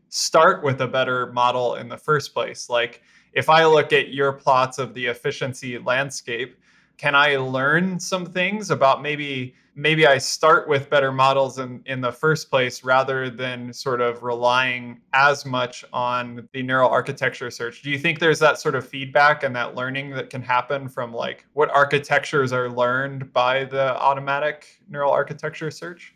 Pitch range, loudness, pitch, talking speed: 125-145 Hz, -21 LUFS, 135 Hz, 175 wpm